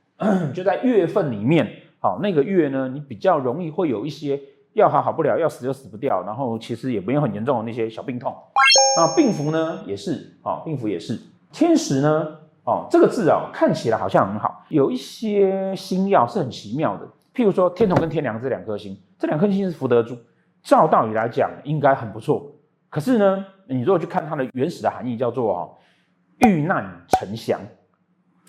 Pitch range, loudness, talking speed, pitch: 130-195 Hz, -21 LUFS, 290 characters per minute, 155 Hz